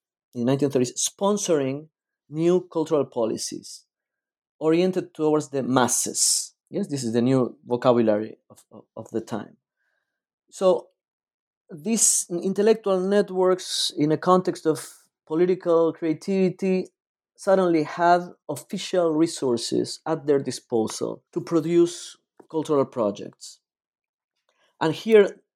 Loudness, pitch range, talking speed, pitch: -23 LUFS, 140-185 Hz, 105 wpm, 160 Hz